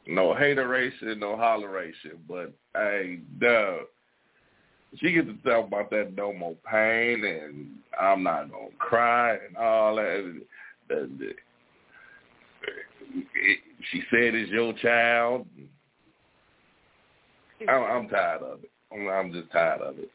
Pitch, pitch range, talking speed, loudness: 115 Hz, 105-120 Hz, 115 wpm, -26 LUFS